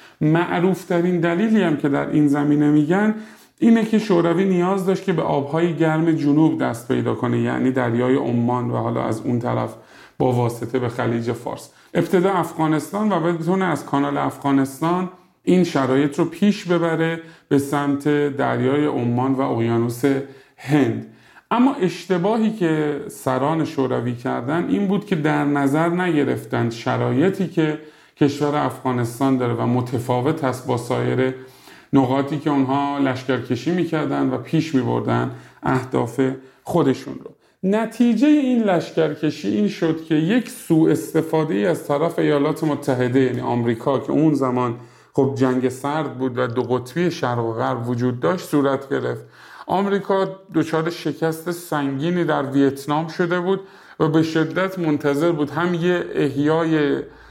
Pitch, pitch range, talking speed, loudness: 150 Hz, 130-170 Hz, 140 wpm, -20 LUFS